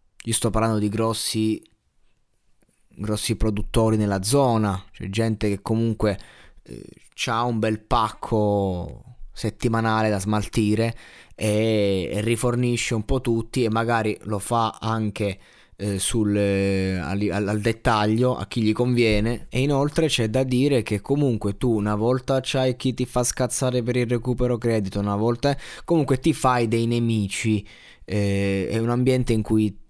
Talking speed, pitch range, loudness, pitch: 150 wpm, 105-125 Hz, -23 LUFS, 115 Hz